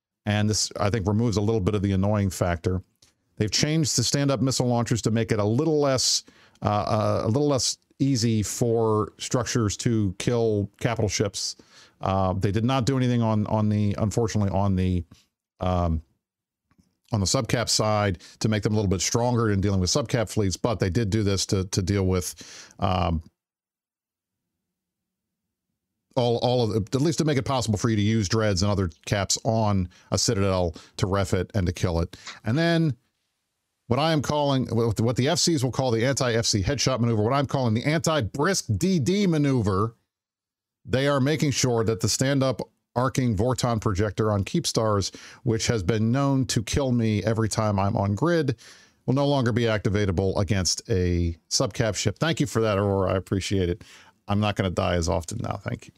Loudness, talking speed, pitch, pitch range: -24 LUFS, 190 wpm, 110 Hz, 100-125 Hz